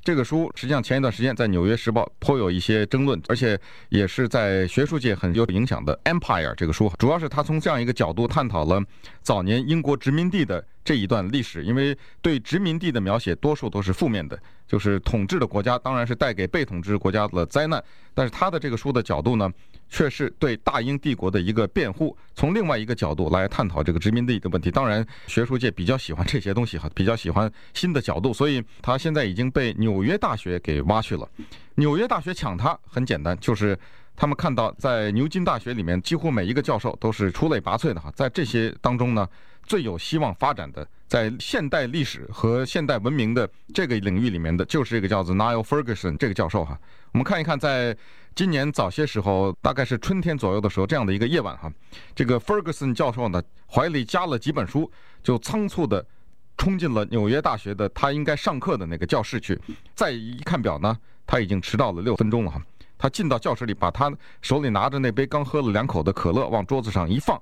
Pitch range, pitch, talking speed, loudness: 100-140 Hz, 115 Hz, 350 characters per minute, -24 LUFS